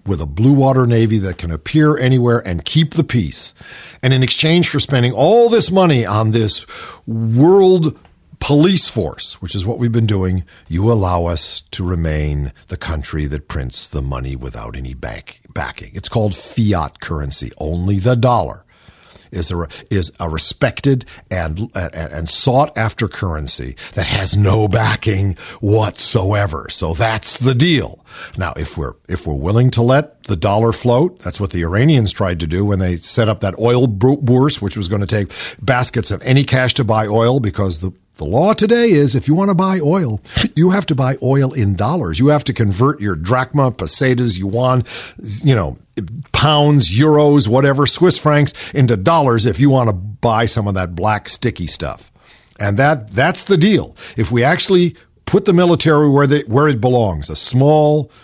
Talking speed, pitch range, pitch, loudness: 180 wpm, 95-140 Hz, 115 Hz, -15 LUFS